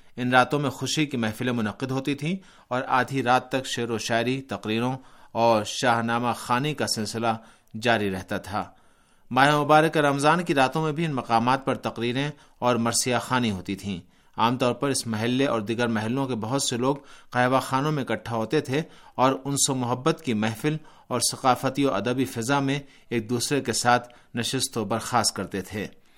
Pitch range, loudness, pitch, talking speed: 115-135 Hz, -25 LUFS, 125 Hz, 185 wpm